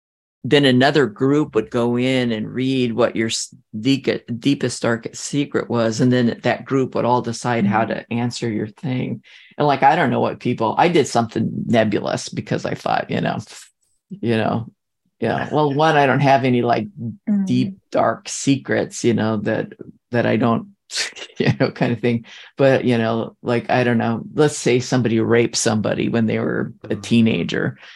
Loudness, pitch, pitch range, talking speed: -19 LUFS, 120 Hz, 115-130 Hz, 180 wpm